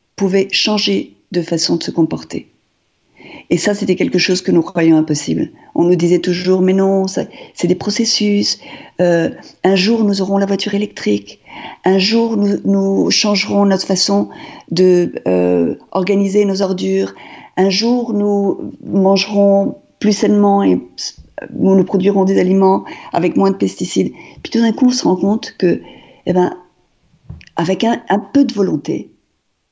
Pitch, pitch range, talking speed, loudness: 195 Hz, 180-205 Hz, 160 wpm, -15 LUFS